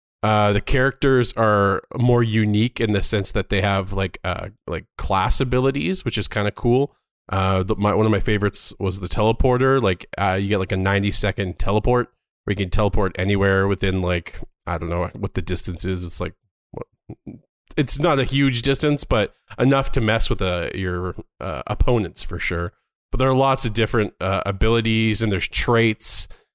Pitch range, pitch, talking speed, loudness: 95-120 Hz, 105 Hz, 190 wpm, -21 LUFS